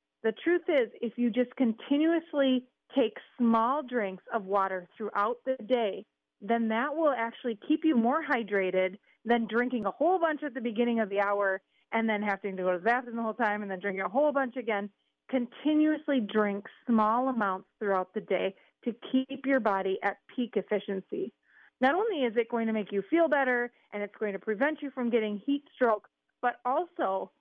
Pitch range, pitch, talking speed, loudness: 205-265 Hz, 235 Hz, 195 wpm, -30 LUFS